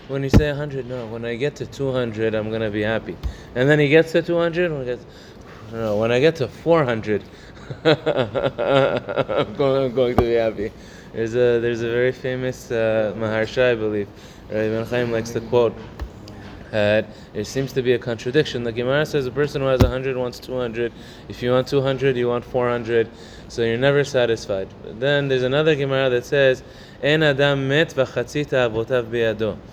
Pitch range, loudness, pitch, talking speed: 110-135 Hz, -21 LUFS, 125 Hz, 190 wpm